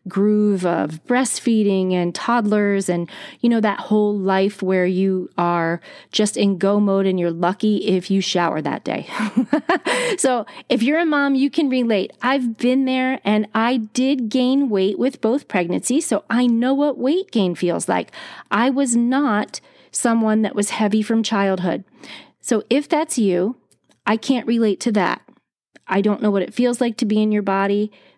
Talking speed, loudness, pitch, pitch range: 175 wpm, -19 LUFS, 215 Hz, 195-255 Hz